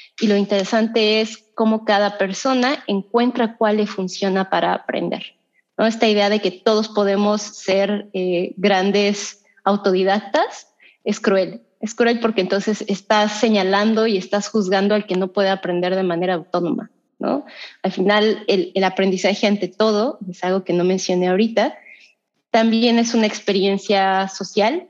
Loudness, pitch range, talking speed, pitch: -19 LUFS, 190-220 Hz, 150 wpm, 205 Hz